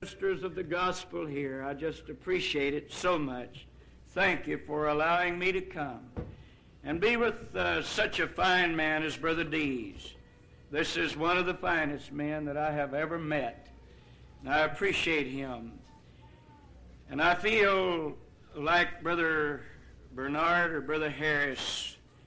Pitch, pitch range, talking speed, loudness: 155 Hz, 140-175 Hz, 145 wpm, -30 LUFS